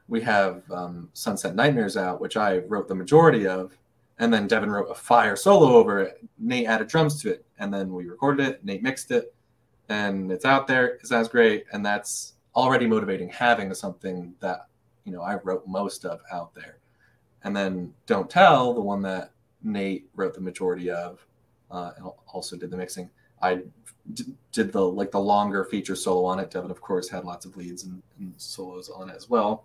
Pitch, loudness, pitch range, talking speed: 100 Hz, -24 LUFS, 90-120 Hz, 200 wpm